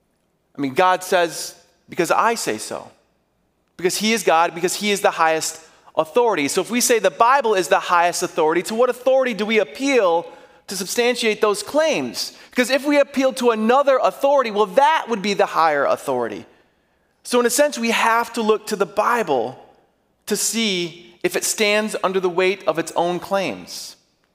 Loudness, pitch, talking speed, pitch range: -19 LUFS, 200 Hz, 185 wpm, 175-240 Hz